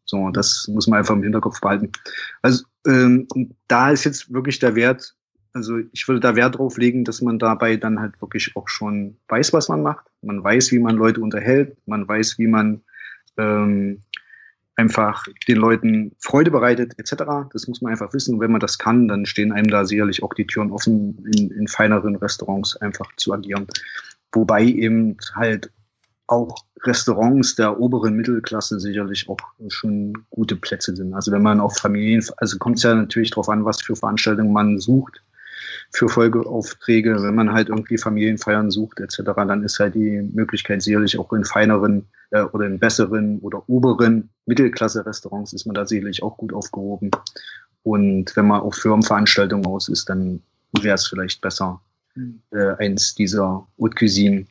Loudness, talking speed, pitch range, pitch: -19 LUFS, 175 wpm, 105-115 Hz, 110 Hz